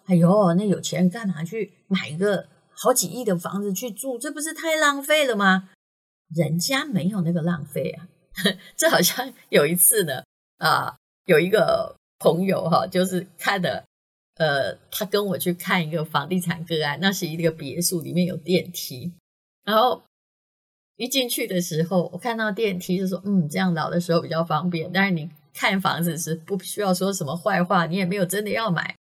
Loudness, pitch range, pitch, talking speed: -23 LUFS, 170-205 Hz, 180 Hz, 265 characters per minute